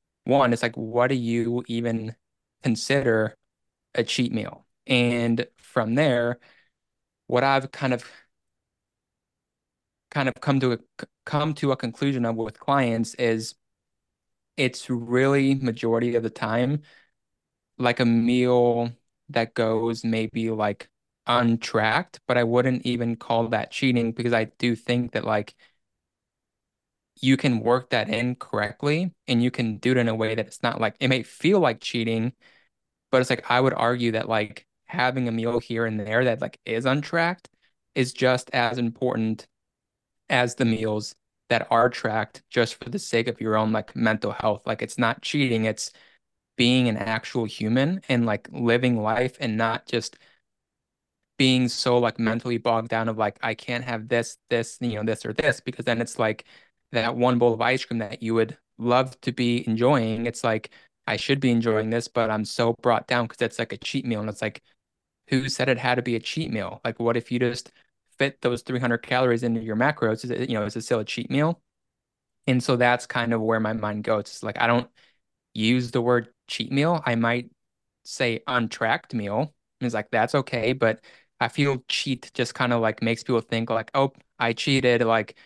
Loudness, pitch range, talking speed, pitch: -24 LUFS, 115-125 Hz, 185 wpm, 120 Hz